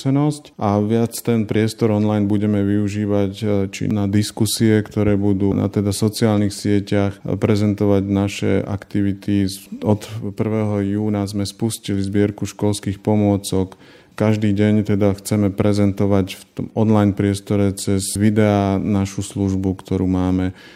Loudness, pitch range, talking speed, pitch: -19 LUFS, 100-105 Hz, 120 wpm, 100 Hz